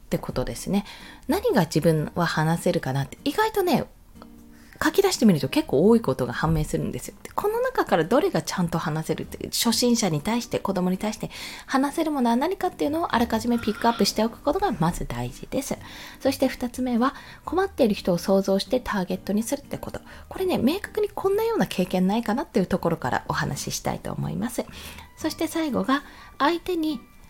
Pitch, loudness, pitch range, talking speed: 225 Hz, -25 LUFS, 180-285 Hz, 430 characters per minute